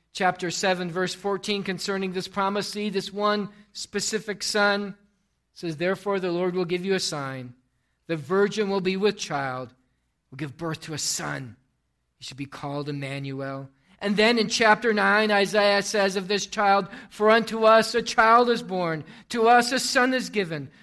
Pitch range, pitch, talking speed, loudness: 160-210 Hz, 195 Hz, 175 wpm, -24 LUFS